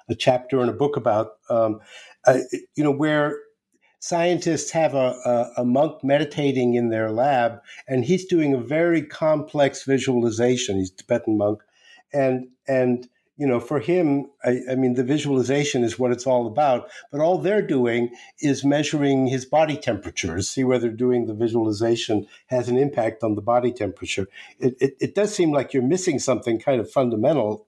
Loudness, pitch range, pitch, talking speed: -22 LUFS, 120-145 Hz, 130 Hz, 175 wpm